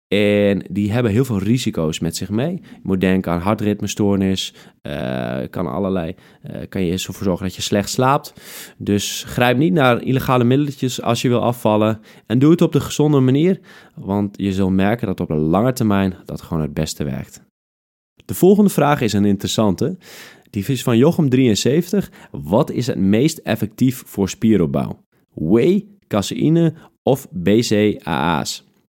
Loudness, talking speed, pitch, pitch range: -18 LUFS, 160 wpm, 105 Hz, 95-130 Hz